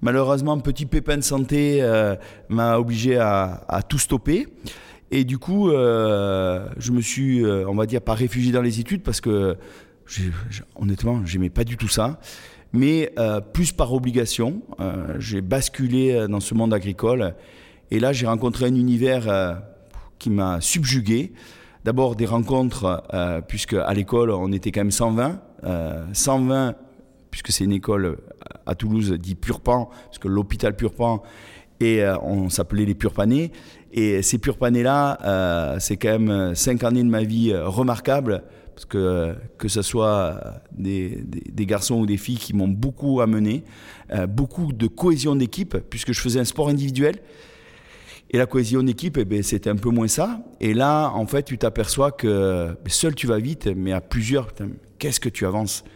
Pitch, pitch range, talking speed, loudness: 115 Hz, 100-130 Hz, 170 wpm, -22 LUFS